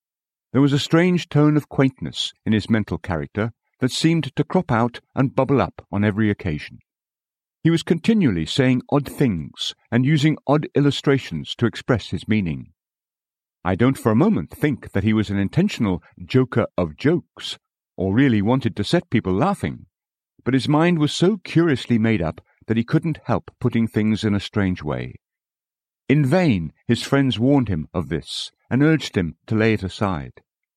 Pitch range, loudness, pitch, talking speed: 100-145 Hz, -21 LUFS, 120 Hz, 175 wpm